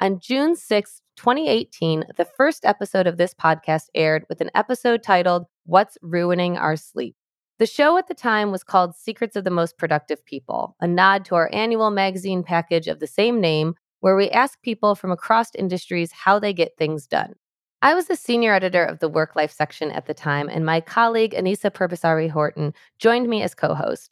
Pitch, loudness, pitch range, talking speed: 185 Hz, -21 LUFS, 160-220 Hz, 195 wpm